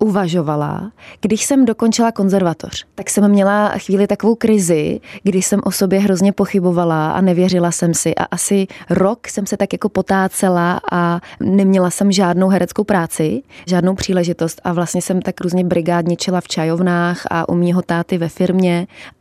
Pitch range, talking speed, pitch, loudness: 175-200 Hz, 160 wpm, 185 Hz, -16 LUFS